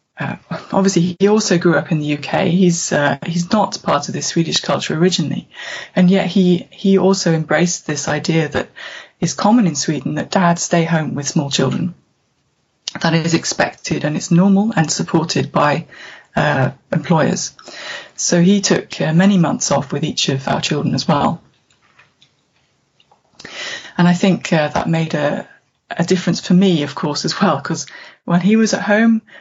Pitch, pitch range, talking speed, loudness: 175 Hz, 160-195 Hz, 180 wpm, -16 LUFS